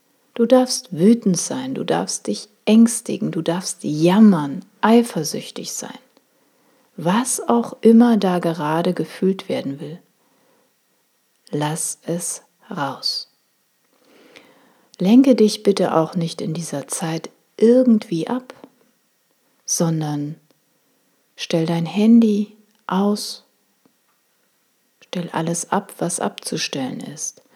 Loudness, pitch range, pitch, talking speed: -19 LUFS, 170-245 Hz, 210 Hz, 100 wpm